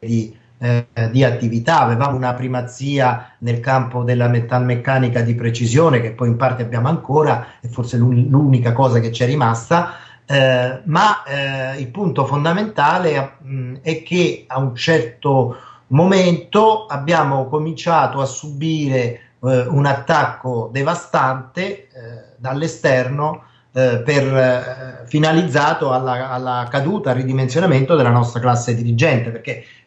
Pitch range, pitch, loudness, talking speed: 125-155 Hz, 130 Hz, -17 LUFS, 130 wpm